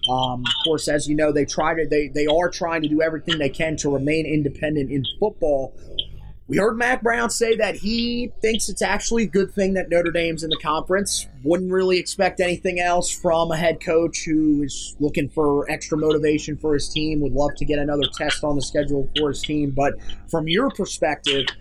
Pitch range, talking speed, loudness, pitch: 145-180 Hz, 210 wpm, -21 LUFS, 155 Hz